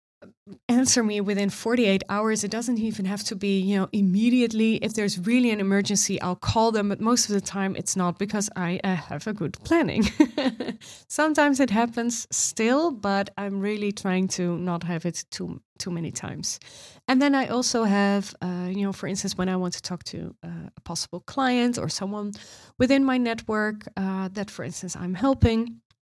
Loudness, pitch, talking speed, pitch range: -25 LUFS, 205 Hz, 195 wpm, 190-235 Hz